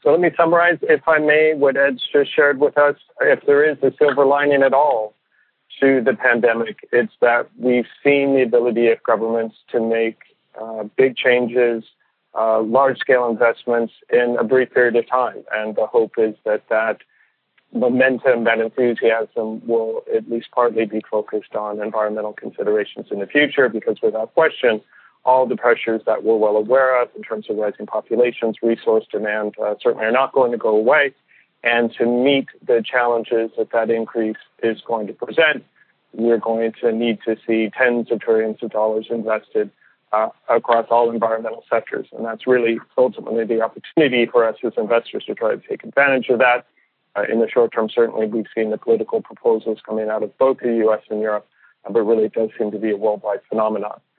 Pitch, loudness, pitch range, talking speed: 120 Hz, -18 LUFS, 110-140 Hz, 190 wpm